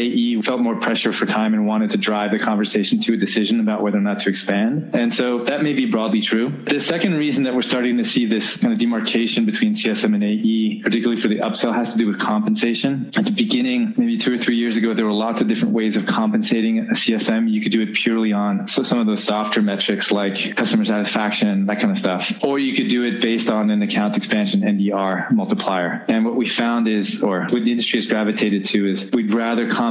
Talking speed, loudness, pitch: 235 wpm, -19 LUFS, 120 Hz